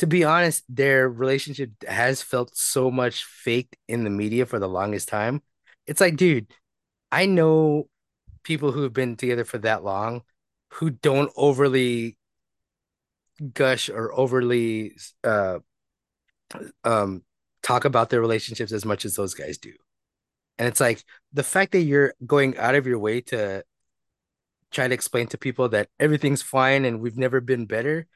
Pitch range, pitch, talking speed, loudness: 115-145 Hz, 130 Hz, 160 wpm, -23 LUFS